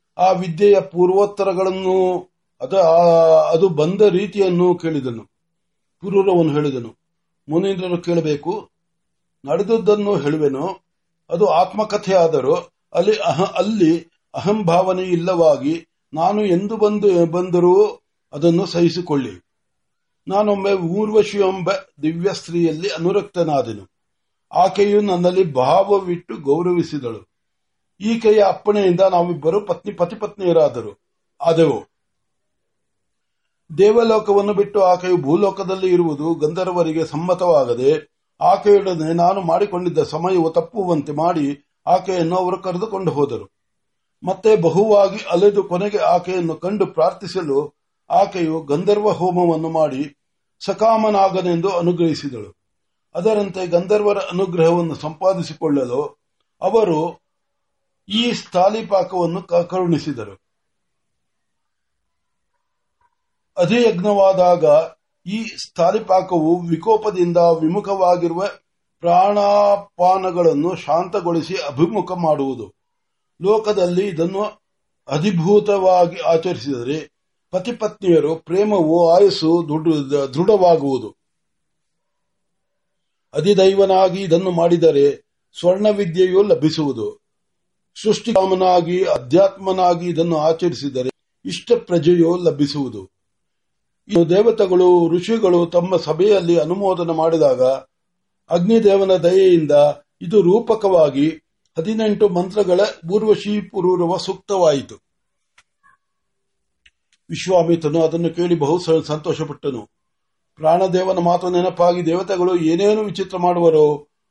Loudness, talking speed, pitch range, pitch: -17 LUFS, 65 wpm, 165-200 Hz, 180 Hz